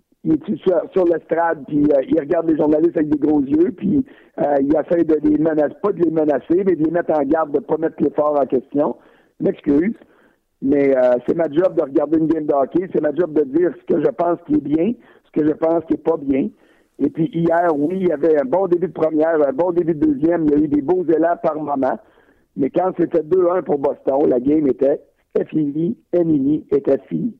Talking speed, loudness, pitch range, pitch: 245 wpm, -18 LUFS, 150-175 Hz, 160 Hz